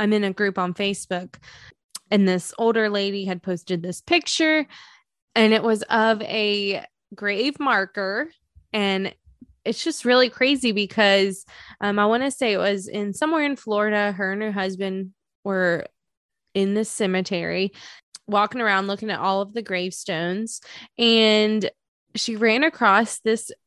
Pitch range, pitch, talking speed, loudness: 195-225 Hz, 205 Hz, 150 wpm, -22 LUFS